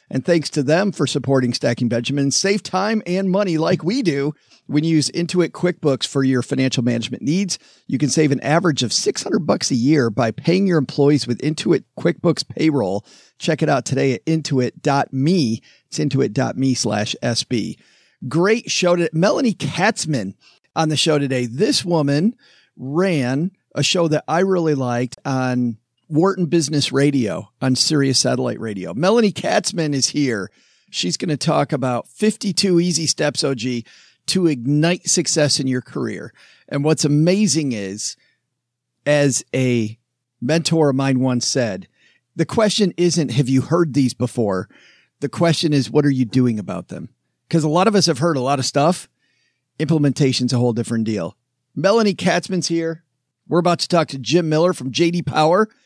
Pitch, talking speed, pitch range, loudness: 145 Hz, 165 wpm, 130-170 Hz, -19 LUFS